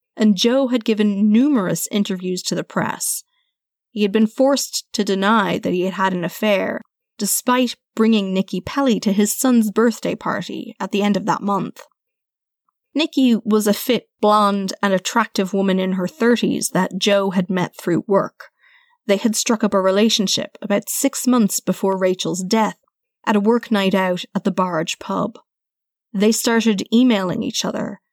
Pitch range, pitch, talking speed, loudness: 195-240 Hz, 210 Hz, 170 wpm, -19 LUFS